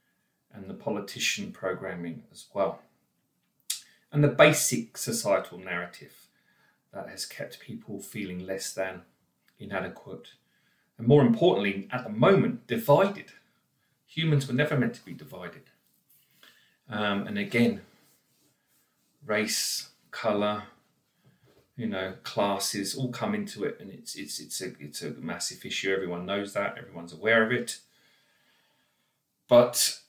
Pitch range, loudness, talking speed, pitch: 95-125 Hz, -28 LUFS, 125 wpm, 100 Hz